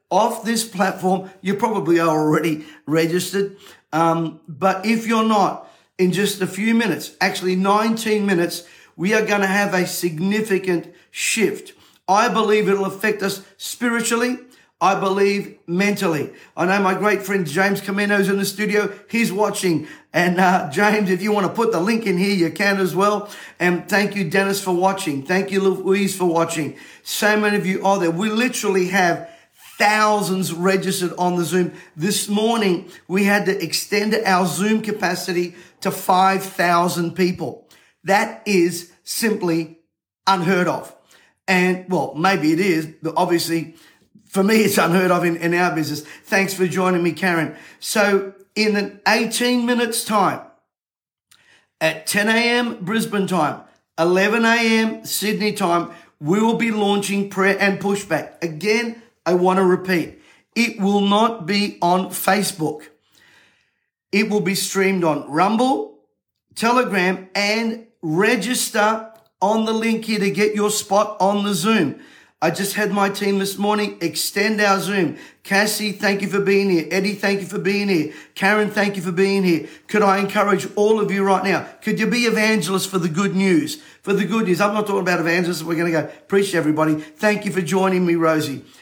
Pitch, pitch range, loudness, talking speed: 195 Hz, 180-210 Hz, -19 LUFS, 165 wpm